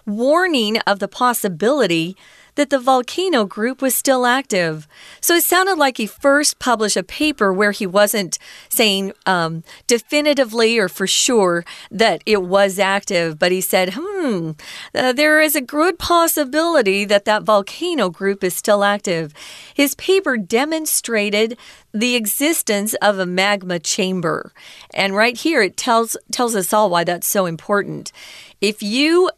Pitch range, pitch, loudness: 195-275 Hz, 215 Hz, -17 LUFS